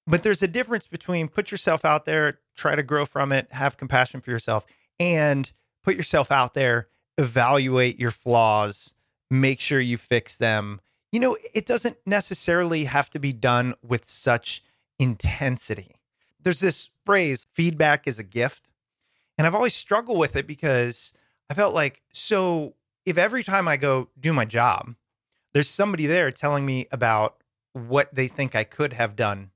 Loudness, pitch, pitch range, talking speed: -23 LUFS, 140 Hz, 120-165 Hz, 165 wpm